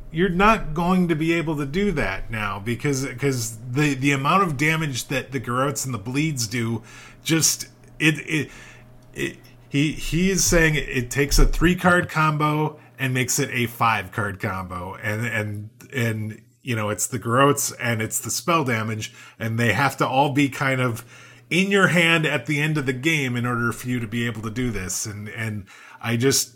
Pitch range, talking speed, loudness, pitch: 115-150 Hz, 200 wpm, -22 LUFS, 130 Hz